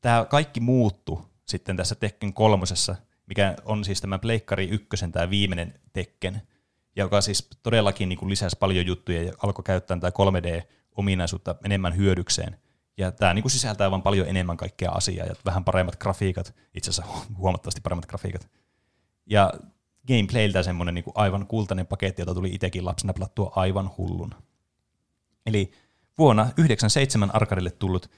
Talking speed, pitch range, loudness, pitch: 150 wpm, 90-105 Hz, -25 LUFS, 95 Hz